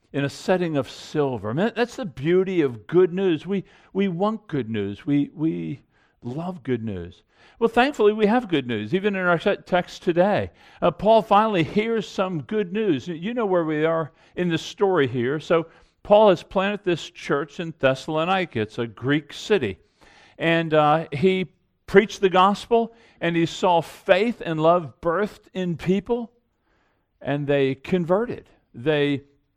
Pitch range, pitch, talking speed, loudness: 145-200 Hz, 175 Hz, 165 wpm, -23 LUFS